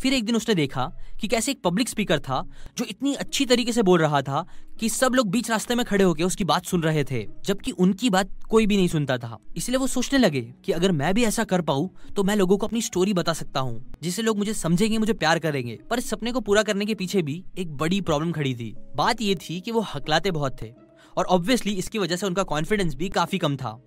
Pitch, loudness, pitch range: 185 Hz, -24 LUFS, 155-220 Hz